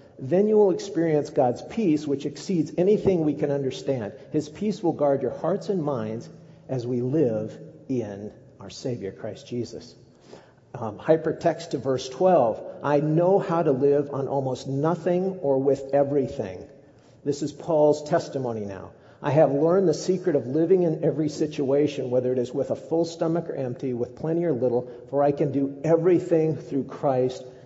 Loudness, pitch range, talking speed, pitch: -24 LUFS, 130-165 Hz, 170 wpm, 145 Hz